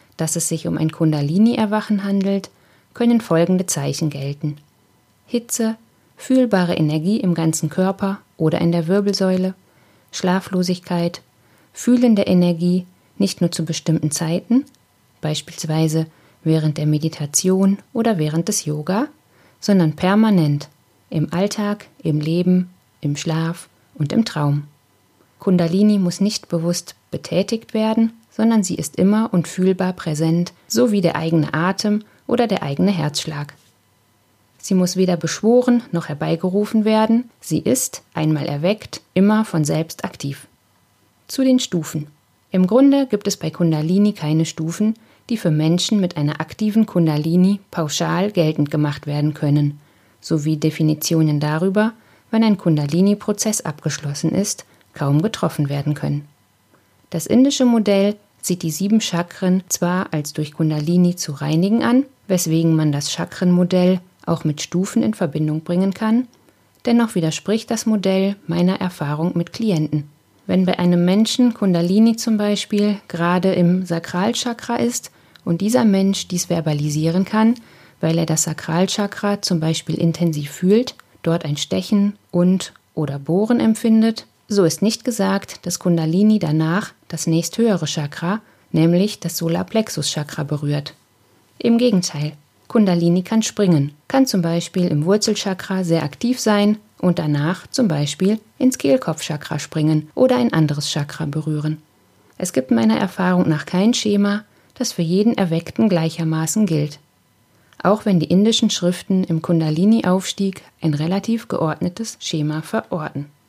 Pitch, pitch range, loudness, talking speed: 175 Hz, 155-205 Hz, -19 LUFS, 135 wpm